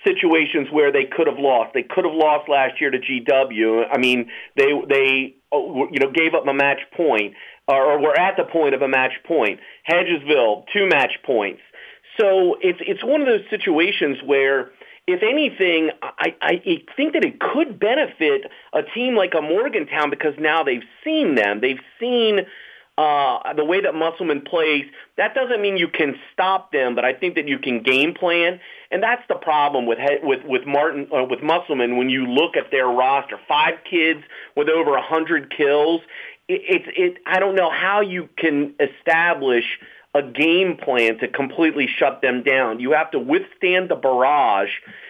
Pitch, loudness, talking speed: 160 Hz, -19 LUFS, 180 wpm